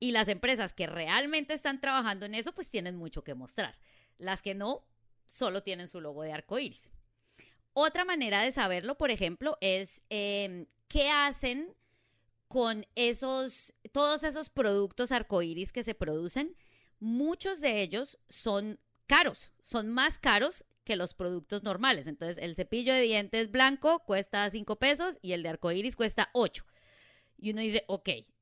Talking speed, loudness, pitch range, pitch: 160 wpm, -31 LUFS, 180-265 Hz, 215 Hz